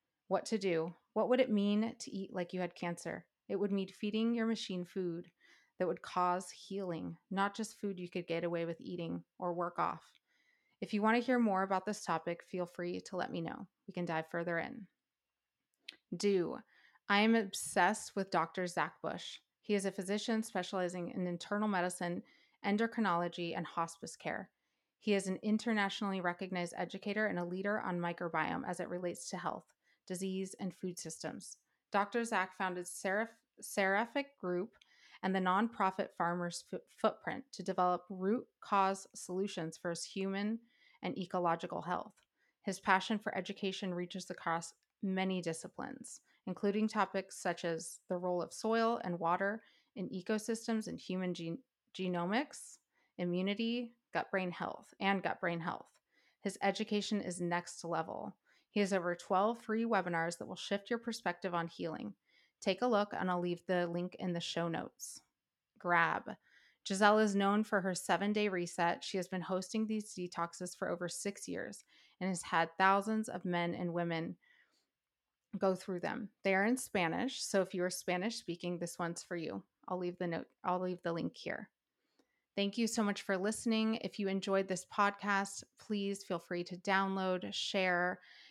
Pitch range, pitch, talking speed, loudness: 175-210 Hz, 190 Hz, 165 wpm, -37 LUFS